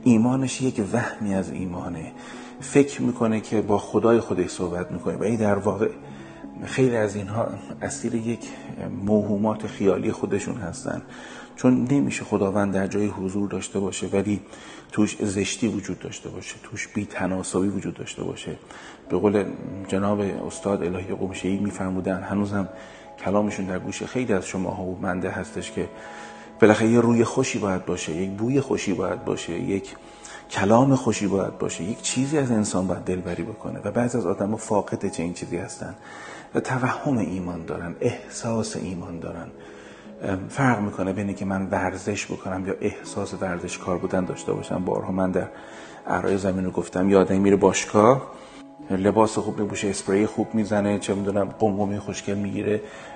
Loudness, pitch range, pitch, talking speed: -25 LUFS, 95-110 Hz, 100 Hz, 155 wpm